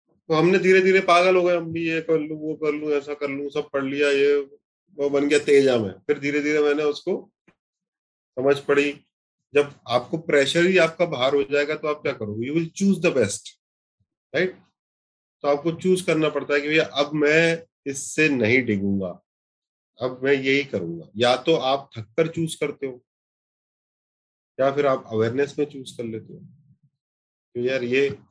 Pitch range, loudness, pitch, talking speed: 135-160 Hz, -22 LUFS, 145 Hz, 185 wpm